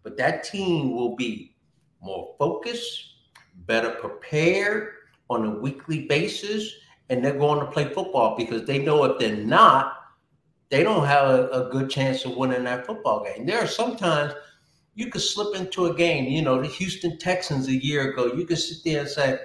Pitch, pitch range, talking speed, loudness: 145 Hz, 130-180 Hz, 185 wpm, -24 LUFS